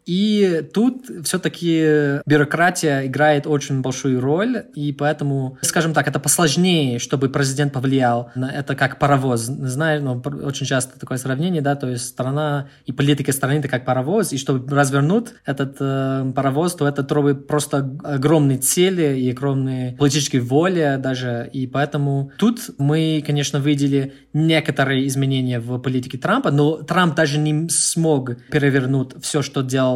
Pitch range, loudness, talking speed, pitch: 135-155 Hz, -19 LUFS, 150 wpm, 145 Hz